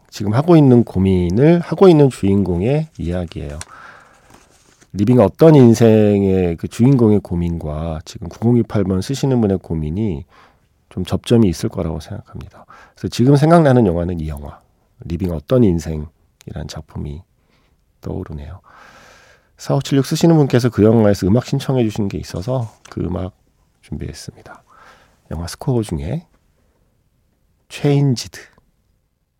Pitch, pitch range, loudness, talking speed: 100 Hz, 85-125 Hz, -15 LUFS, 280 characters per minute